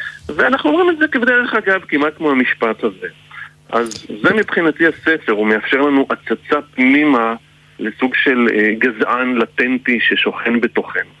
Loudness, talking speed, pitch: -15 LUFS, 135 wpm, 140 Hz